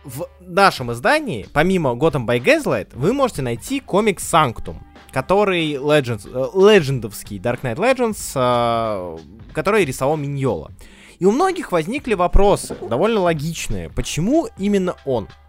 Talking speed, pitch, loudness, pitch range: 120 wpm, 155 Hz, -19 LUFS, 120-200 Hz